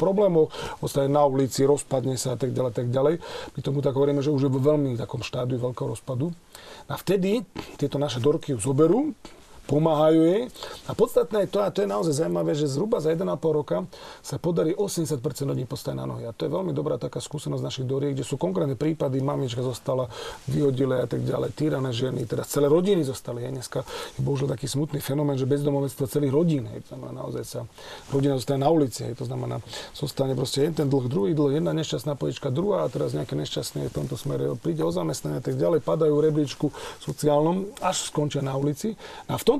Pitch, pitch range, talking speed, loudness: 145 Hz, 130-155 Hz, 200 wpm, -25 LUFS